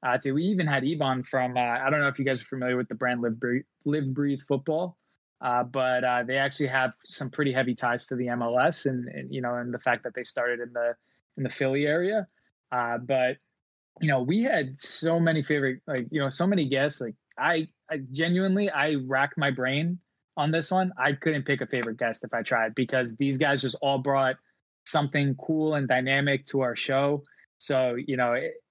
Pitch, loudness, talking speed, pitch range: 135 Hz, -27 LUFS, 220 wpm, 125-150 Hz